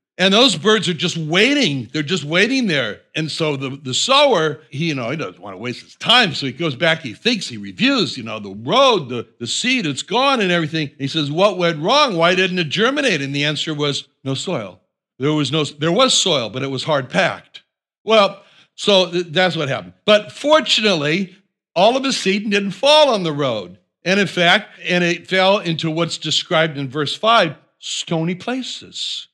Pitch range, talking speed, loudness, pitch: 150-205 Hz, 210 wpm, -17 LUFS, 170 Hz